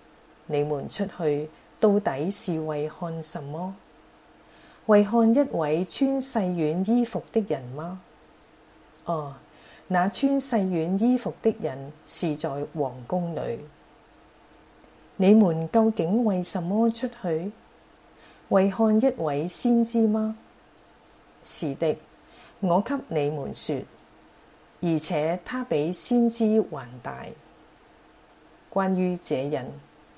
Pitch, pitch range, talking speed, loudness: 185 Hz, 160-225 Hz, 145 characters per minute, -25 LUFS